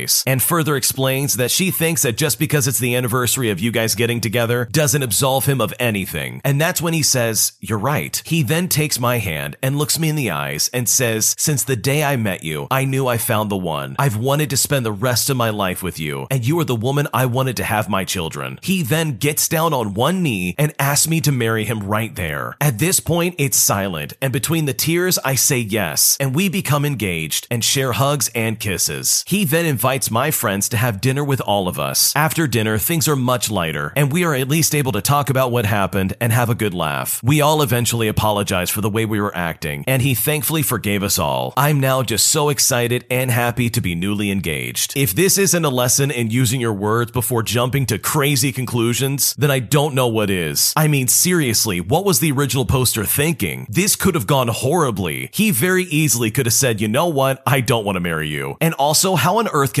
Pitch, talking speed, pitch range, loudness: 130 Hz, 230 wpm, 110-145 Hz, -17 LUFS